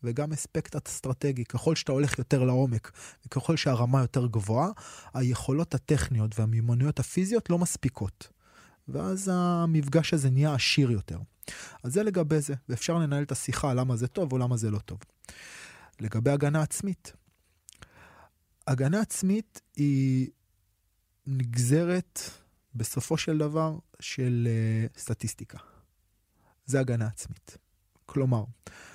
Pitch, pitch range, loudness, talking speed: 130 Hz, 110-150 Hz, -28 LUFS, 120 wpm